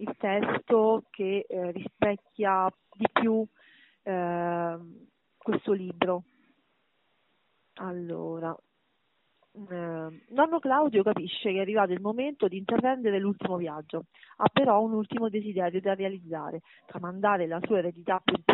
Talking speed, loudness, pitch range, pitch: 115 wpm, -29 LUFS, 175-215 Hz, 195 Hz